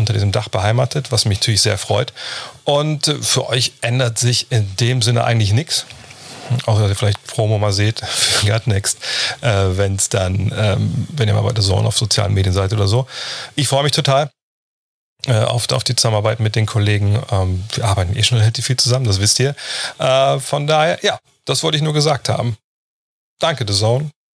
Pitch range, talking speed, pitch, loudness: 105-130 Hz, 195 wpm, 115 Hz, -16 LUFS